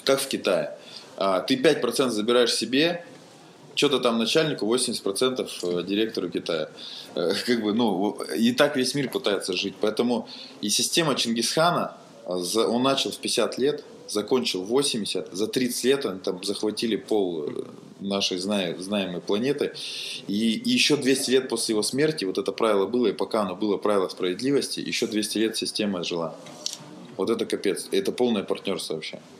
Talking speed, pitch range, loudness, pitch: 150 wpm, 100-130 Hz, -25 LUFS, 115 Hz